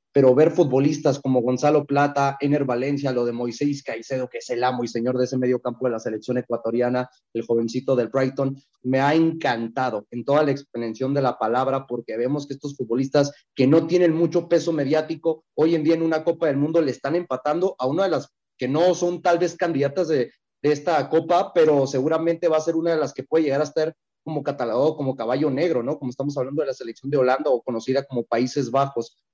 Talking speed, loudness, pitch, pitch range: 220 wpm, -22 LUFS, 140 Hz, 125-155 Hz